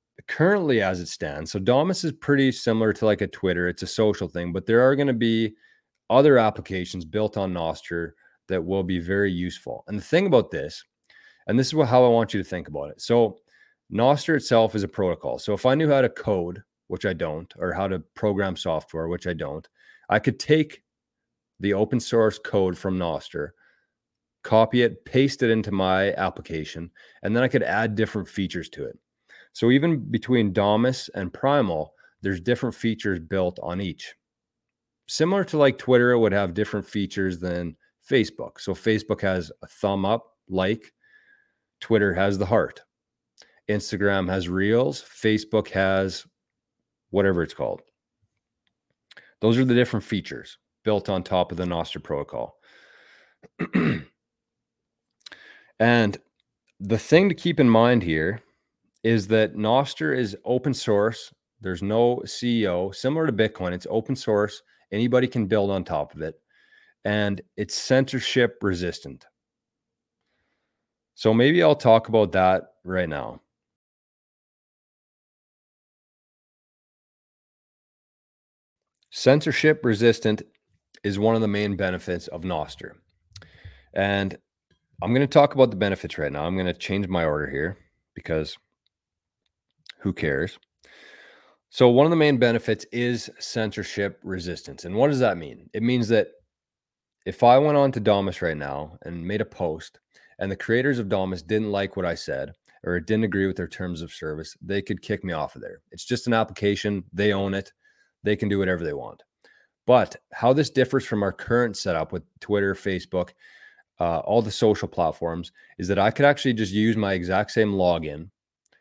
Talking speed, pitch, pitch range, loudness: 160 wpm, 105 Hz, 95-120 Hz, -23 LUFS